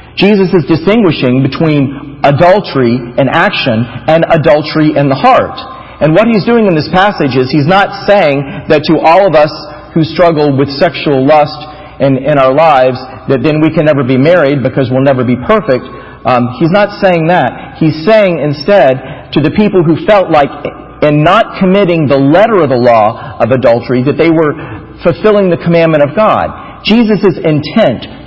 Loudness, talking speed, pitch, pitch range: -8 LUFS, 175 wpm, 155 Hz, 140-180 Hz